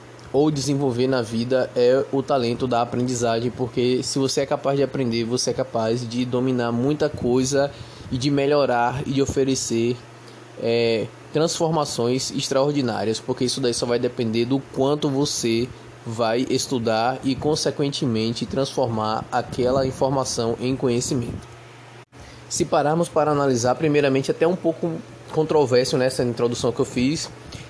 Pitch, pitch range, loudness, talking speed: 130 Hz, 120-140 Hz, -22 LUFS, 140 wpm